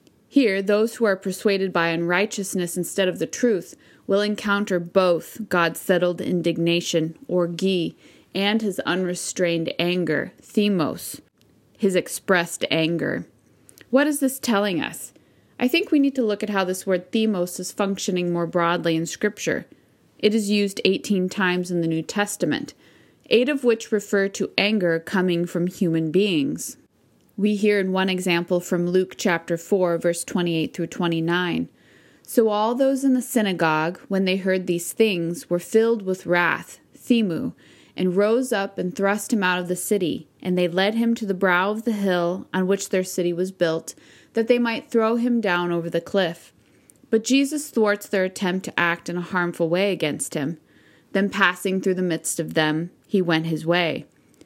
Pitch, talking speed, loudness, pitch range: 185 Hz, 170 wpm, -22 LUFS, 175-210 Hz